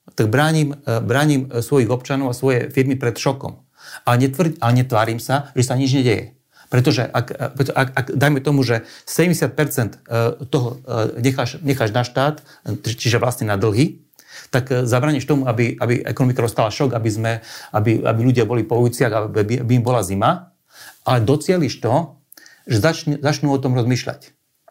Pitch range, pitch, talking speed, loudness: 120-140 Hz, 130 Hz, 155 wpm, -19 LUFS